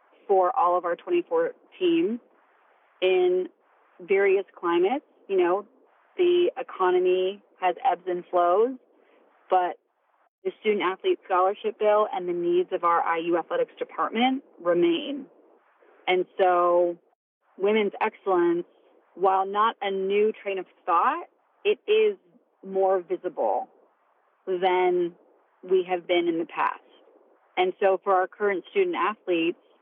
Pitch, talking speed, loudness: 220 Hz, 125 wpm, -25 LUFS